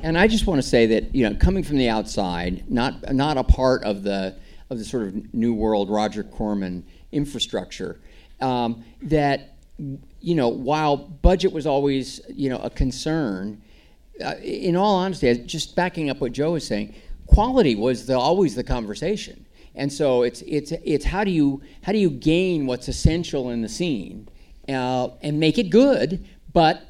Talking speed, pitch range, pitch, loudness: 180 wpm, 115-160 Hz, 135 Hz, -22 LUFS